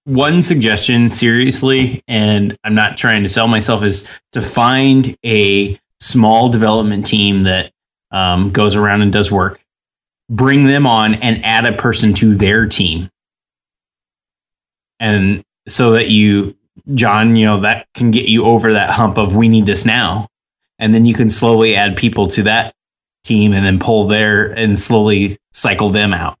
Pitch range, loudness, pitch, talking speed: 100-115 Hz, -12 LUFS, 110 Hz, 165 wpm